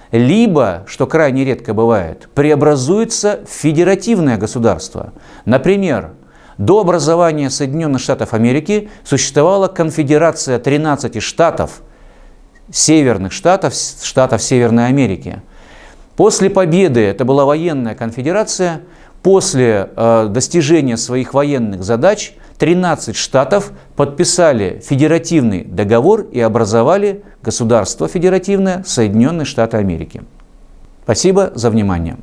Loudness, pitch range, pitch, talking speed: -13 LUFS, 115-175 Hz, 140 Hz, 95 wpm